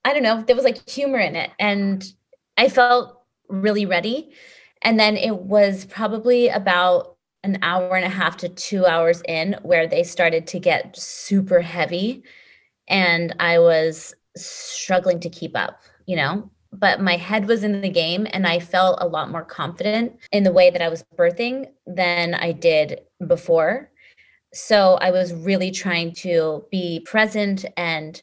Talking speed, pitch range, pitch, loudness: 170 wpm, 175-215 Hz, 185 Hz, -20 LUFS